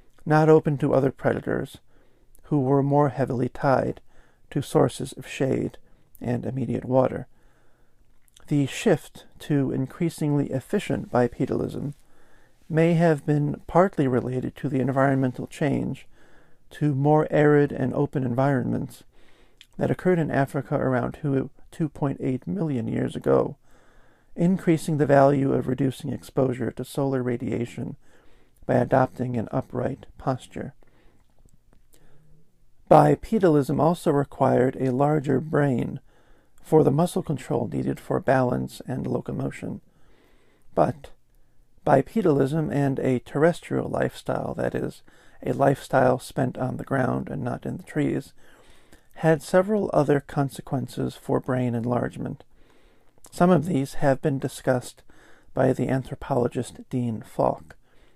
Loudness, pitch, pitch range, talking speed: -24 LUFS, 135 Hz, 125-150 Hz, 120 wpm